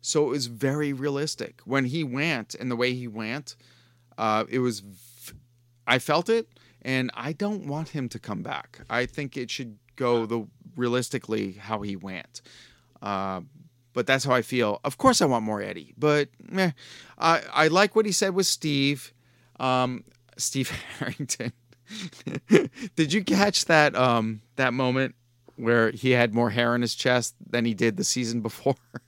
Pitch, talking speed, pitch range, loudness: 125 Hz, 175 wpm, 120-145 Hz, -26 LUFS